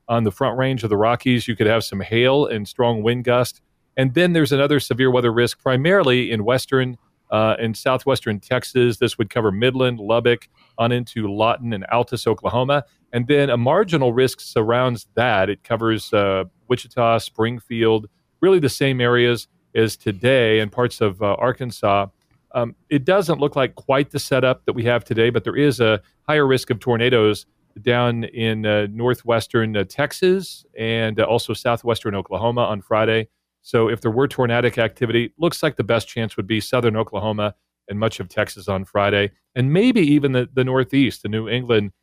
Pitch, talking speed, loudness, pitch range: 120 Hz, 180 wpm, -19 LUFS, 110-130 Hz